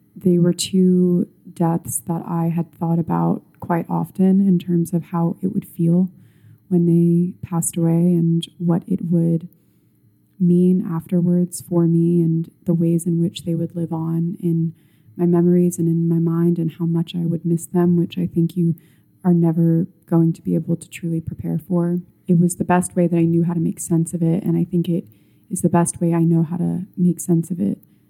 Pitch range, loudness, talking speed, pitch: 165-175 Hz, -19 LUFS, 205 wpm, 170 Hz